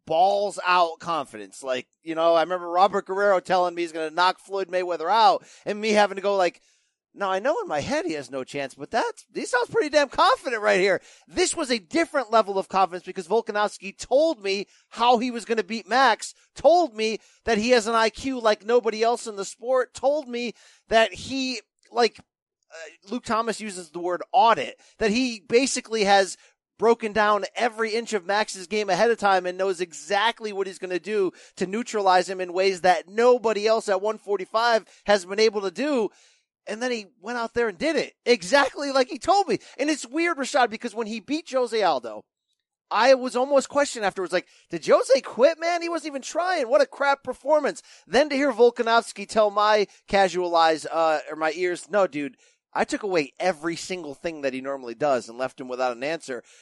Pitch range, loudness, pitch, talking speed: 185-250 Hz, -24 LUFS, 215 Hz, 205 wpm